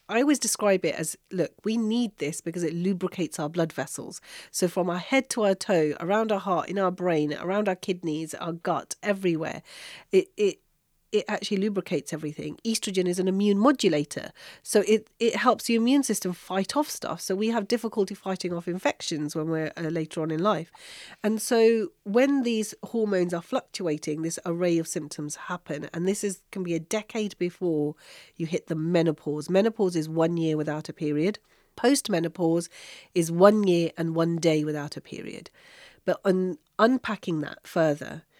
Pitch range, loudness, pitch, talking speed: 165-215 Hz, -27 LUFS, 185 Hz, 180 wpm